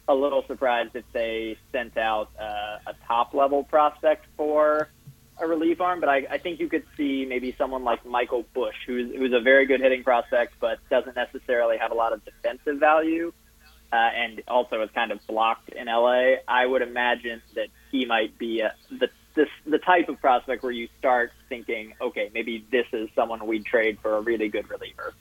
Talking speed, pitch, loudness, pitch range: 200 wpm, 125 Hz, -25 LUFS, 115-150 Hz